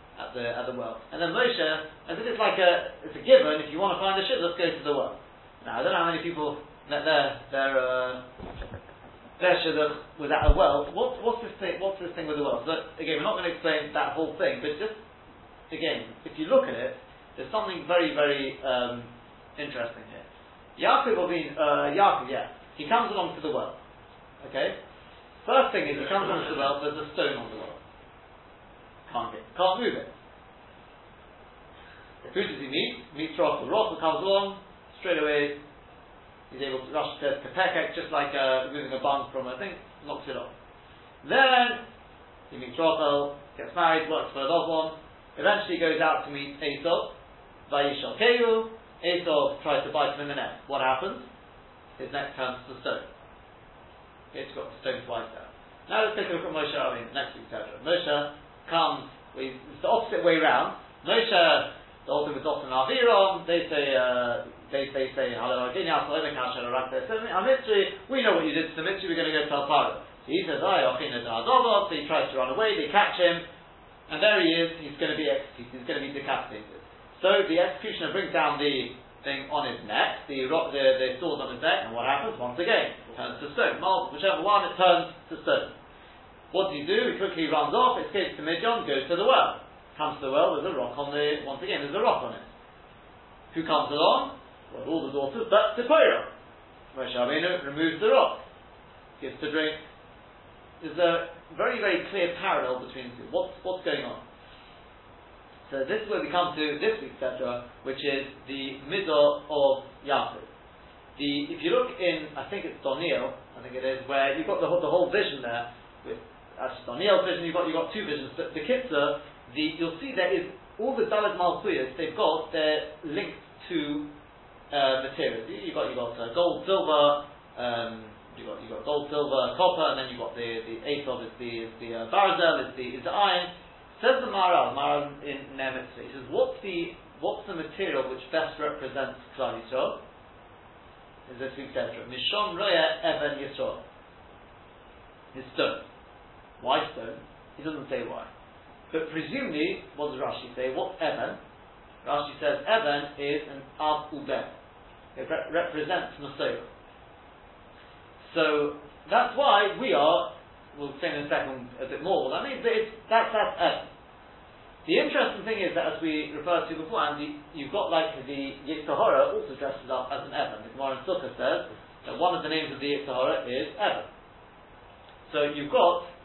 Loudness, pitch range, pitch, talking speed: -27 LUFS, 135-180 Hz, 155 Hz, 190 wpm